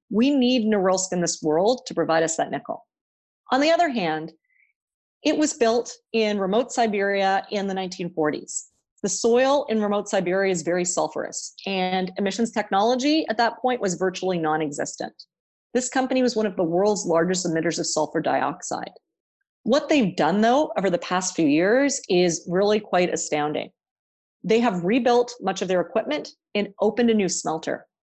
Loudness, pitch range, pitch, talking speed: -23 LUFS, 180-240 Hz, 200 Hz, 165 wpm